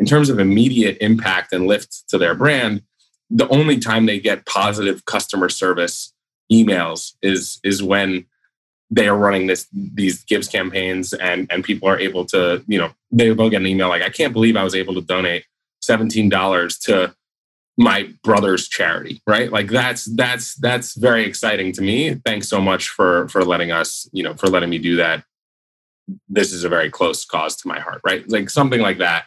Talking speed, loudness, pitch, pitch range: 190 wpm, -17 LUFS, 100 Hz, 95-120 Hz